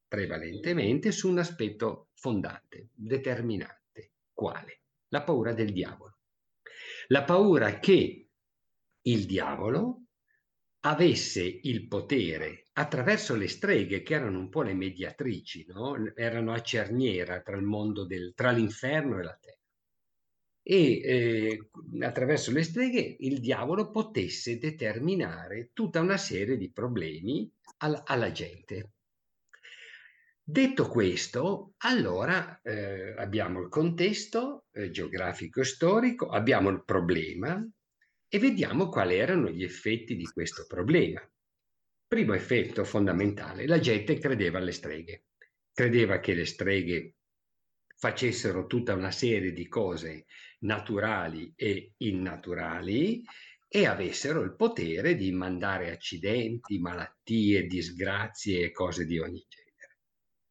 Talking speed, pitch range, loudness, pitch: 115 wpm, 95-150 Hz, -30 LUFS, 110 Hz